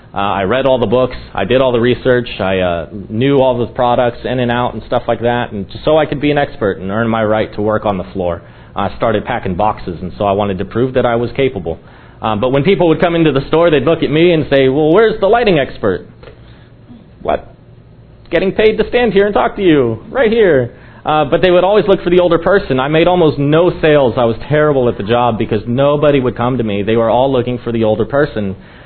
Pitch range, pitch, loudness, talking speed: 115-150 Hz, 125 Hz, -13 LUFS, 255 wpm